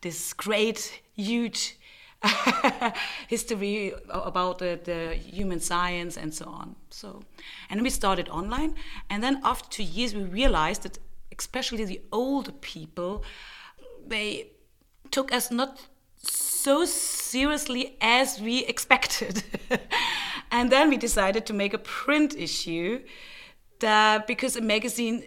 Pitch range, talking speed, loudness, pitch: 195-260 Hz, 125 wpm, -26 LUFS, 230 Hz